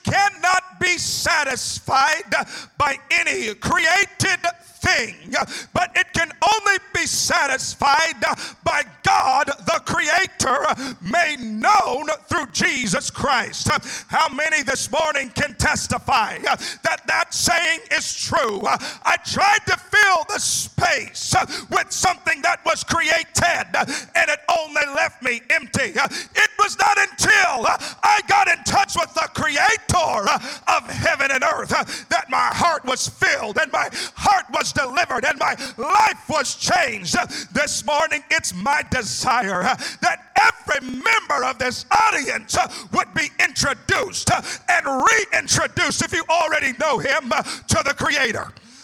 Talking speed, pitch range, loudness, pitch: 130 wpm, 300-390 Hz, -19 LUFS, 335 Hz